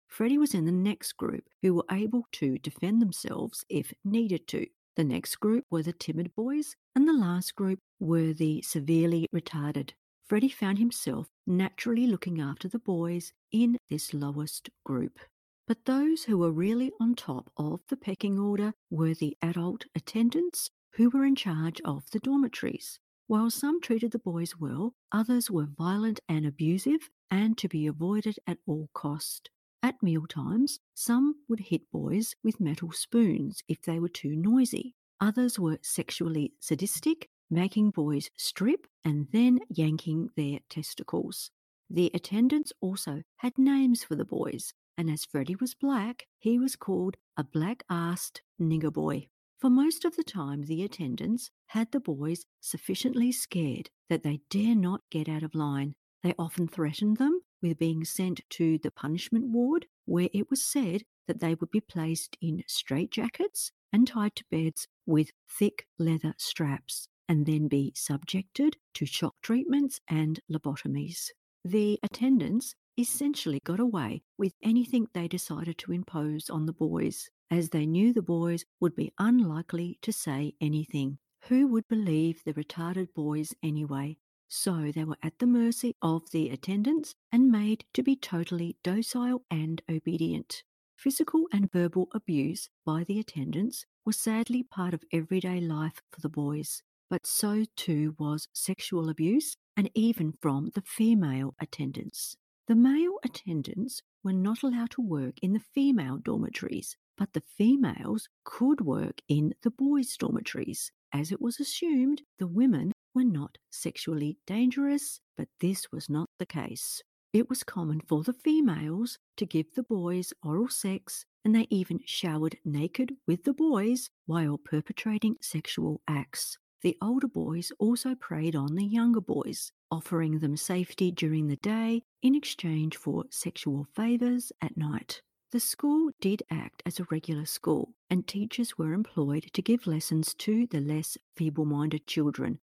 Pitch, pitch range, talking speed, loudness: 185 Hz, 160-235 Hz, 155 wpm, -30 LUFS